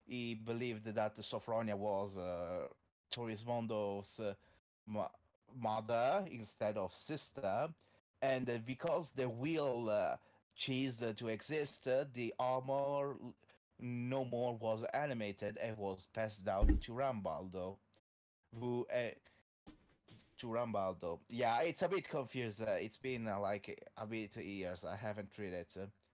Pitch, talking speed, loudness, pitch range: 110 Hz, 135 wpm, -41 LUFS, 100-125 Hz